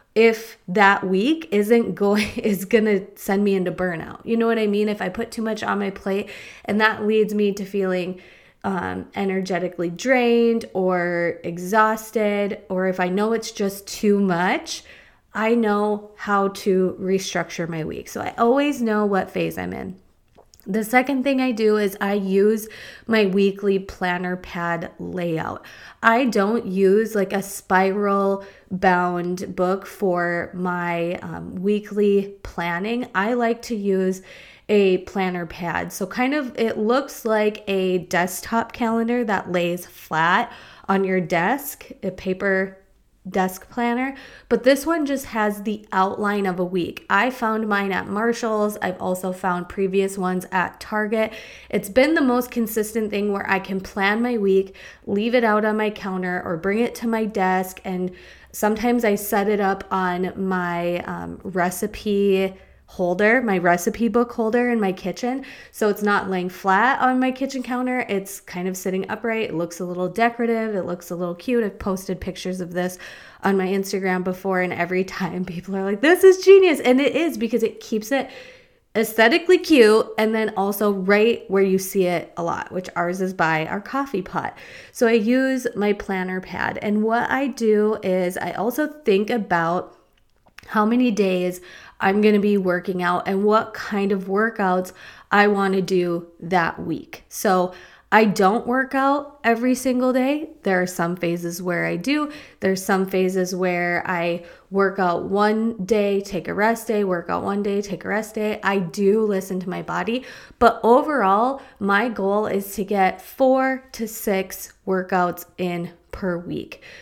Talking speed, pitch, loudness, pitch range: 170 wpm, 200 Hz, -21 LUFS, 185-225 Hz